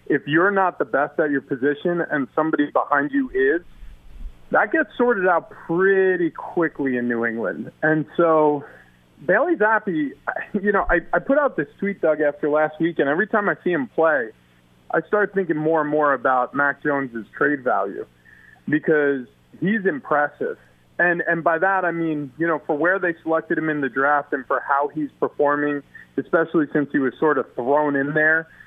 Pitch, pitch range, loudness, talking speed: 150 Hz, 140-175 Hz, -21 LUFS, 185 wpm